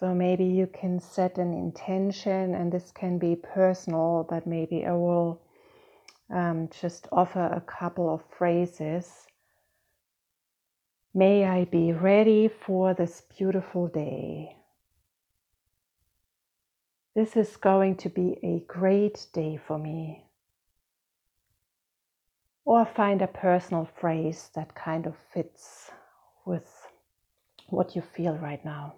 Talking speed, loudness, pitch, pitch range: 115 wpm, -27 LUFS, 175 Hz, 155-185 Hz